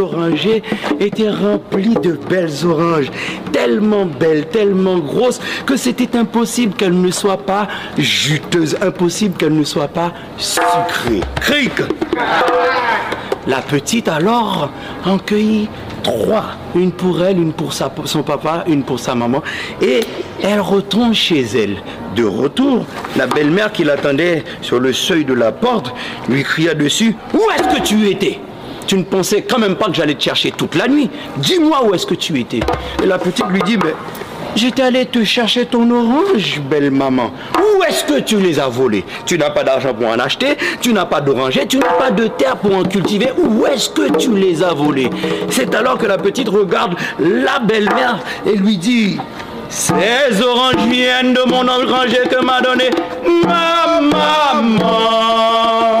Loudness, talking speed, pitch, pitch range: -14 LUFS, 165 wpm, 205 Hz, 175-245 Hz